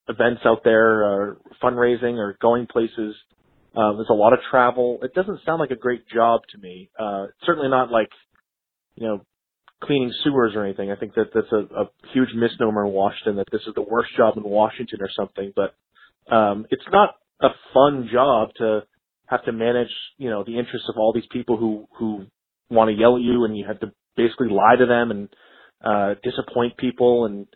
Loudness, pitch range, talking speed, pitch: -21 LUFS, 105-125 Hz, 200 wpm, 115 Hz